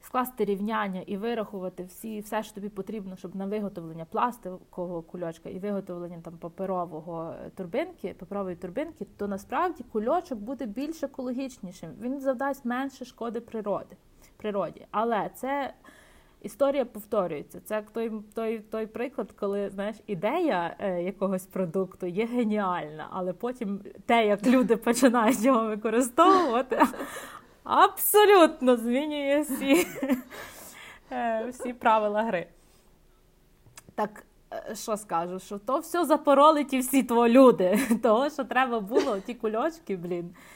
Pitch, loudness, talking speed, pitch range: 220 Hz, -27 LUFS, 120 wpm, 195-260 Hz